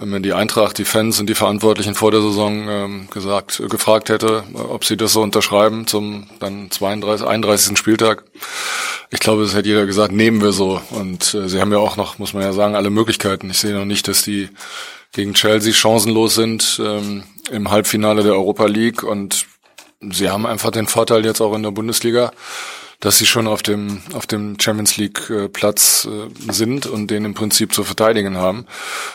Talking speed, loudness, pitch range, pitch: 185 wpm, -16 LUFS, 100-110 Hz, 105 Hz